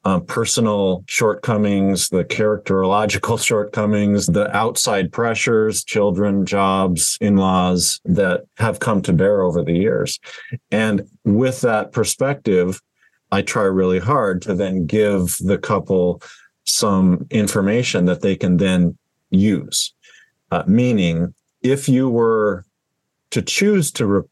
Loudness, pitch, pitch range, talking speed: -18 LUFS, 100 Hz, 95-110 Hz, 120 wpm